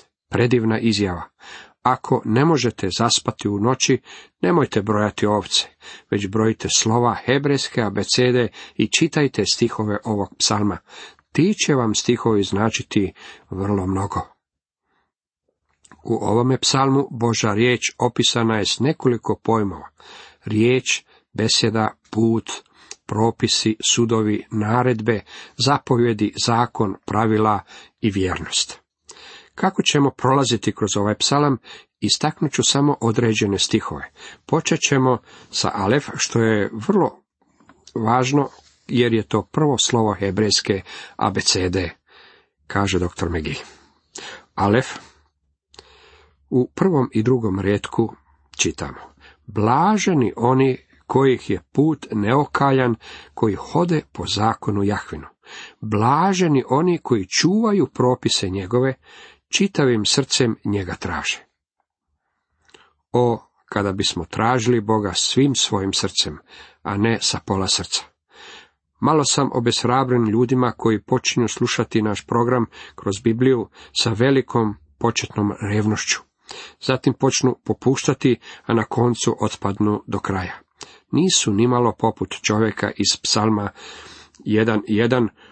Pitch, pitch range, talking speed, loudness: 115 Hz, 105-130 Hz, 105 wpm, -20 LUFS